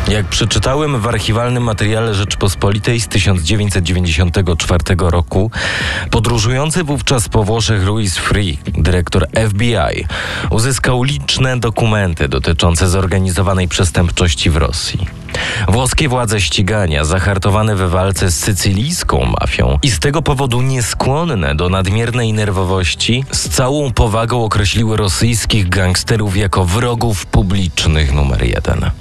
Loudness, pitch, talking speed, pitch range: -14 LUFS, 100 Hz, 110 wpm, 90-115 Hz